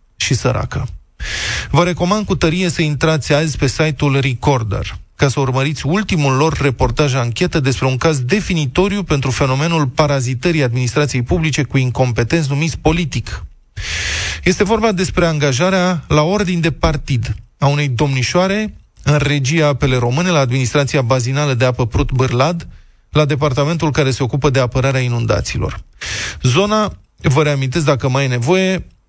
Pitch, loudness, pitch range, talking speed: 145 Hz, -16 LUFS, 130-165 Hz, 140 wpm